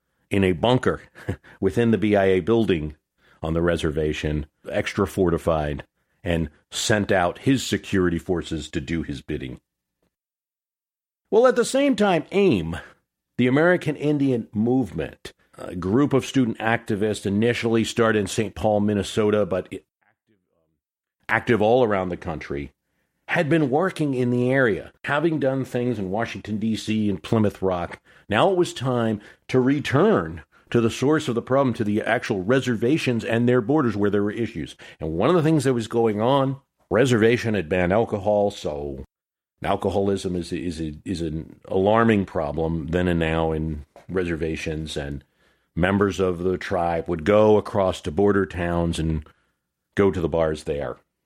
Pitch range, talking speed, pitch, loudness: 85-120 Hz, 155 wpm, 105 Hz, -22 LUFS